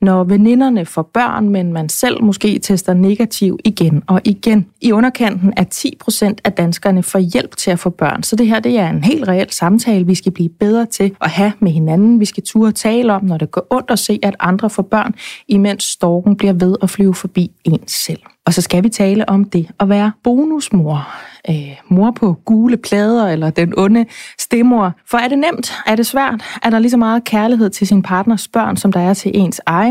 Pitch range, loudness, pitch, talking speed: 185-225 Hz, -14 LUFS, 205 Hz, 220 wpm